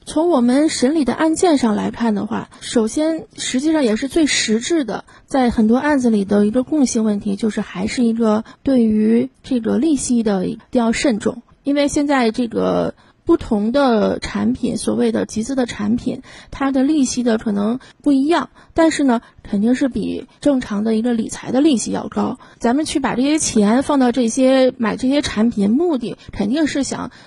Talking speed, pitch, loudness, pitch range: 275 characters per minute, 245 Hz, -17 LUFS, 225-285 Hz